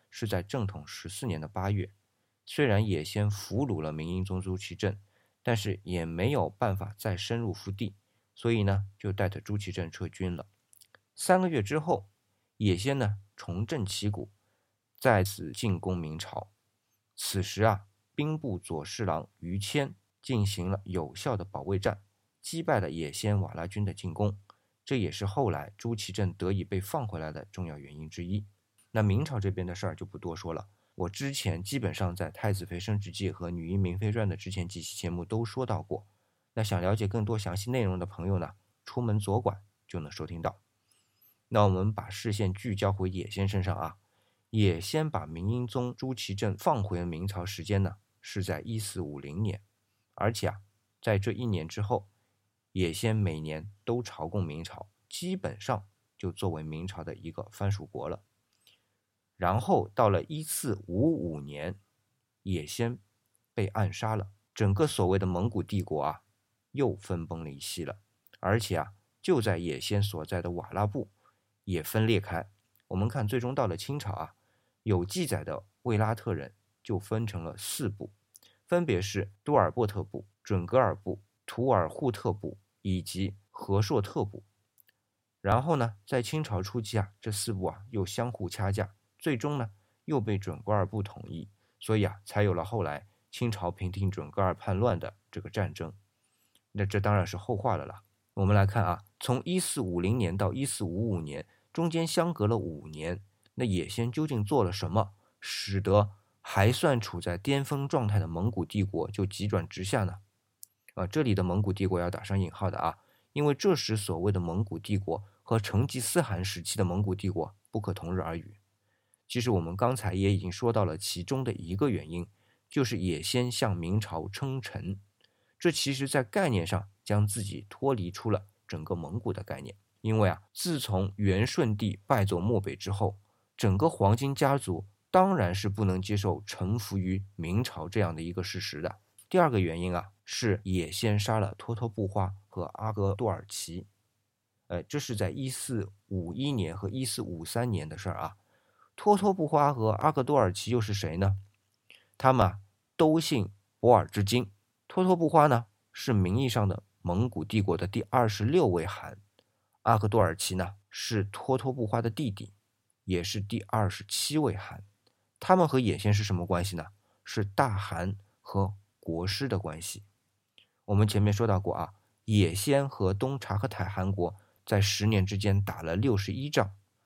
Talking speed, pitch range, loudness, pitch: 255 characters per minute, 95-115 Hz, -31 LUFS, 105 Hz